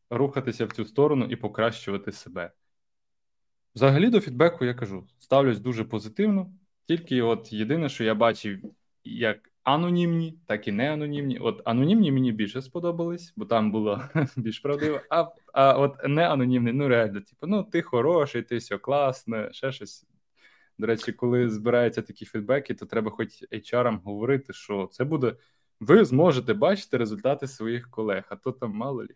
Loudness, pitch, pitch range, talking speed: -25 LUFS, 125 Hz, 110-145 Hz, 155 wpm